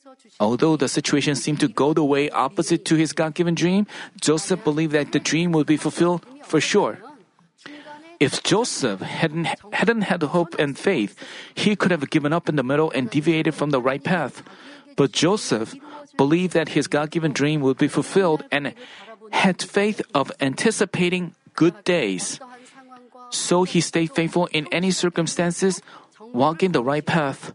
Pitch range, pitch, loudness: 150-200 Hz, 170 Hz, -21 LUFS